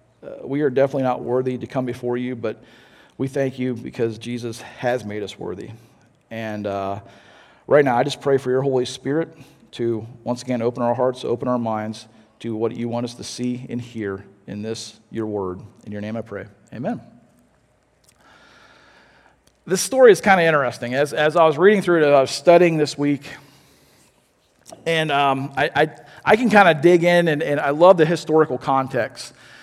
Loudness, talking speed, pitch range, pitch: -20 LUFS, 190 wpm, 115-145 Hz, 125 Hz